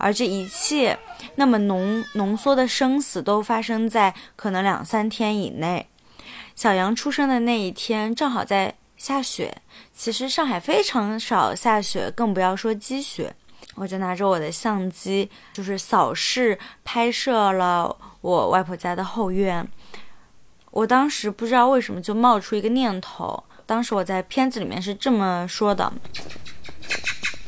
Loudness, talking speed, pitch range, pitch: -22 LUFS, 225 characters per minute, 195-240 Hz, 220 Hz